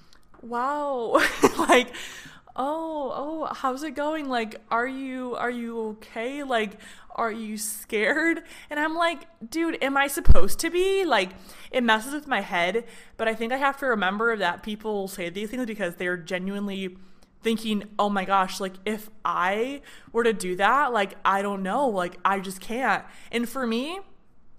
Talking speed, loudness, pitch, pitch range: 170 wpm, -26 LUFS, 230 Hz, 200-275 Hz